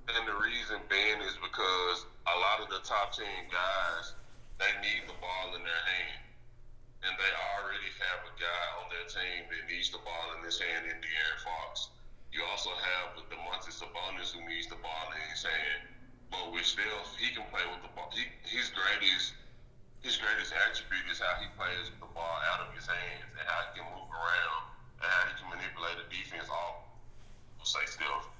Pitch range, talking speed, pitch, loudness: 85-115 Hz, 200 wpm, 95 Hz, -34 LUFS